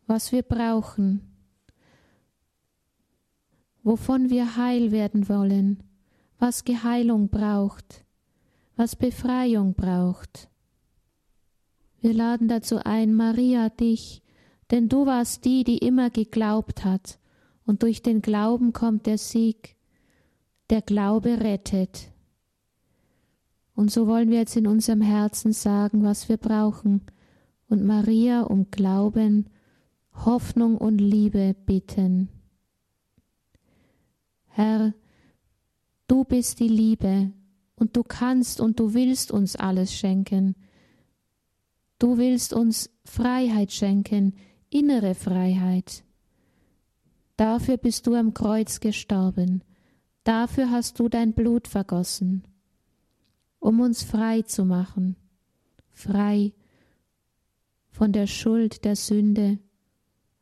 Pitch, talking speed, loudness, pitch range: 215 Hz, 100 wpm, -23 LUFS, 195-230 Hz